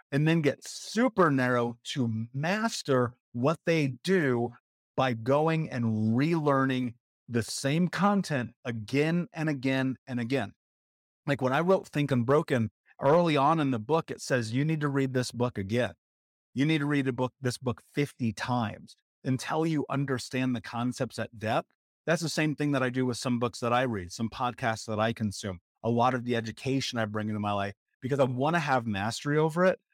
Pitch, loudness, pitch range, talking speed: 130 Hz, -29 LUFS, 115-145 Hz, 190 wpm